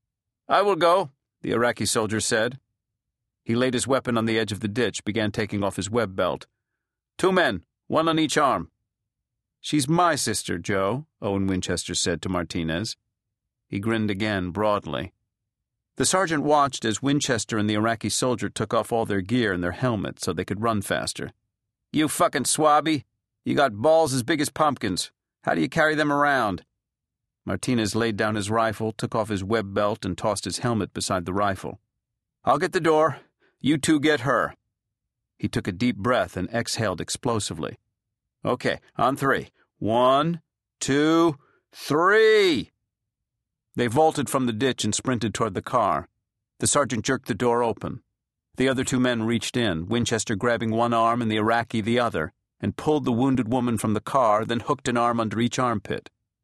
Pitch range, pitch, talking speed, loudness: 105-135 Hz, 115 Hz, 175 wpm, -24 LUFS